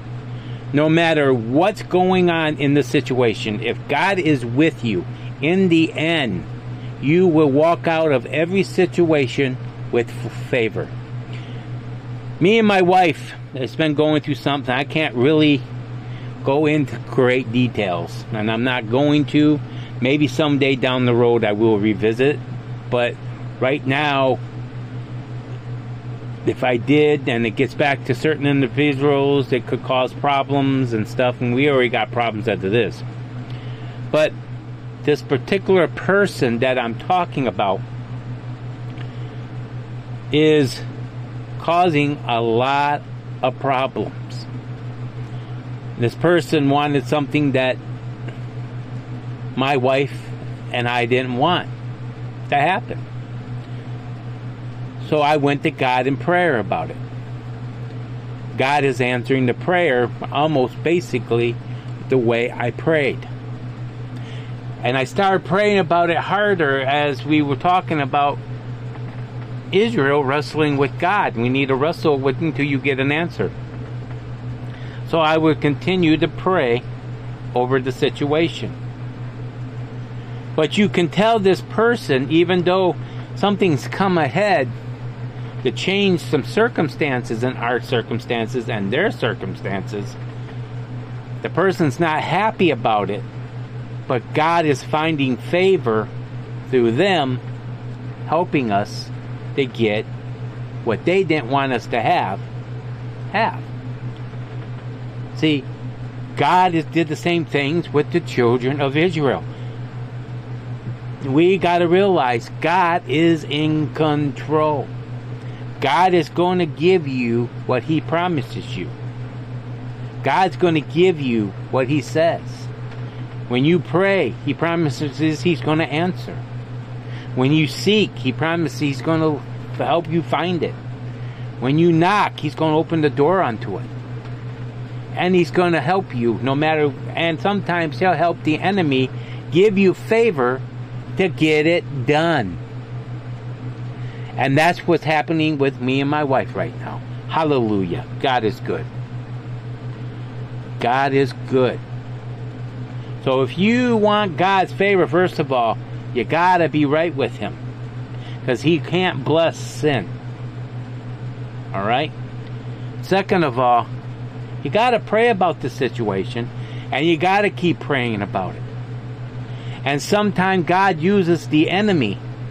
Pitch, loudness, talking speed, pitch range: 125 Hz, -19 LUFS, 125 wpm, 120-150 Hz